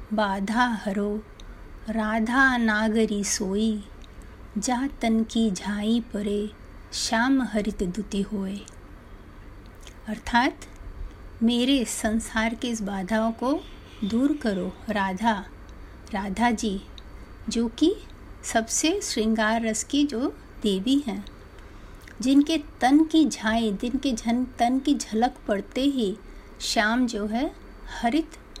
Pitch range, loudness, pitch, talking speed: 205-250 Hz, -25 LUFS, 225 Hz, 105 wpm